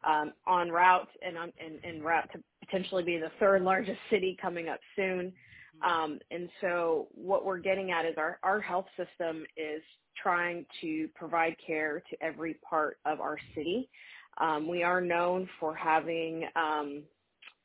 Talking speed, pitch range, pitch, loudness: 160 wpm, 160-185 Hz, 170 Hz, -32 LUFS